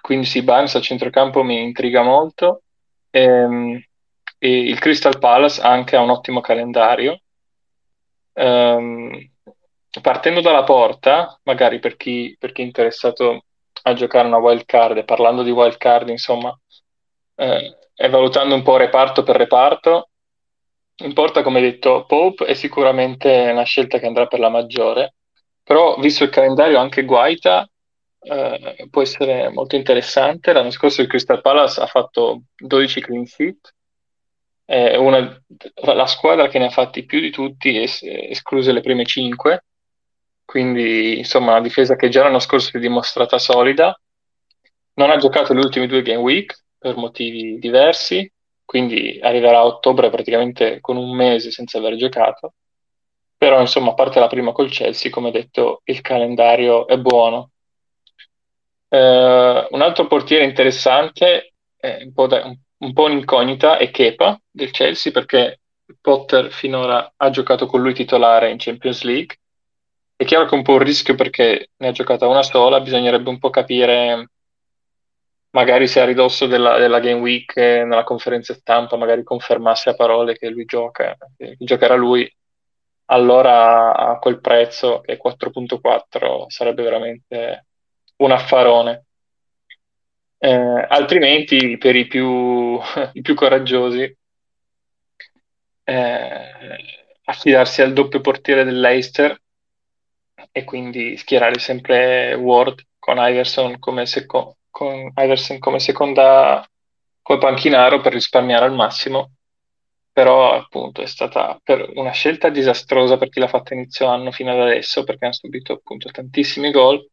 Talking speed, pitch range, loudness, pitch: 145 wpm, 120-135 Hz, -15 LUFS, 125 Hz